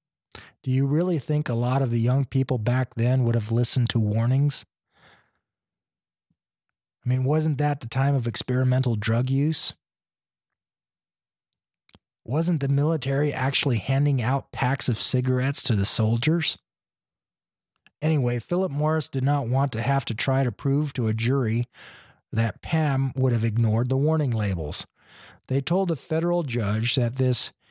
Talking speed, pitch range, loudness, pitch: 150 wpm, 120-145 Hz, -24 LUFS, 130 Hz